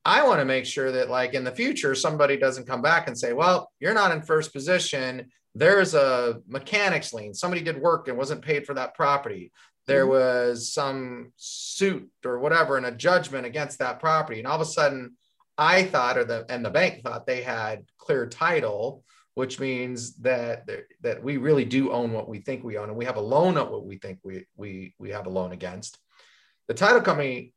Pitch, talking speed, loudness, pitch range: 135 Hz, 210 wpm, -24 LUFS, 125-160 Hz